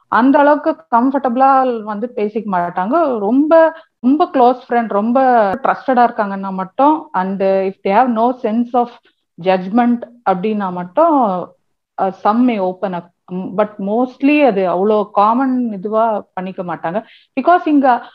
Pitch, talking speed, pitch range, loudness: 230 Hz, 120 wpm, 195-265 Hz, -15 LUFS